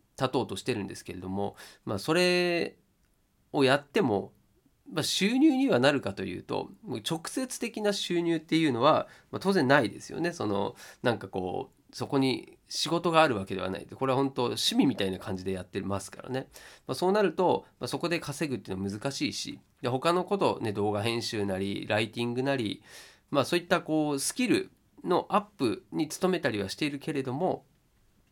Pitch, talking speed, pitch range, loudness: 135 Hz, 370 characters per minute, 105-170 Hz, -29 LUFS